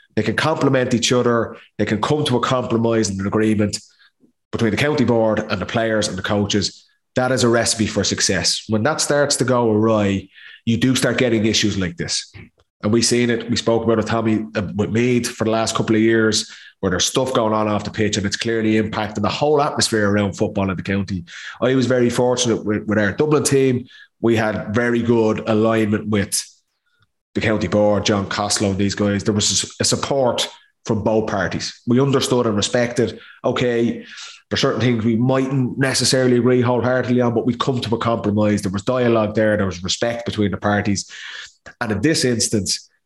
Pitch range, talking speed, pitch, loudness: 105-120 Hz, 200 wpm, 110 Hz, -18 LUFS